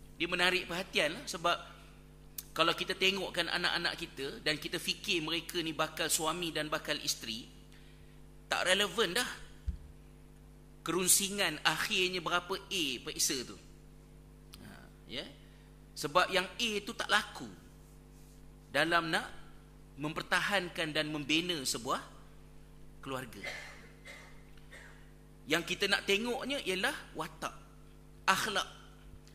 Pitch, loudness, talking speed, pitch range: 170 Hz, -33 LUFS, 100 wpm, 155-185 Hz